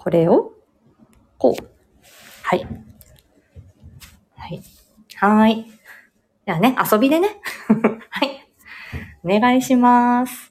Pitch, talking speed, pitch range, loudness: 245 Hz, 155 characters per minute, 215-275 Hz, -18 LUFS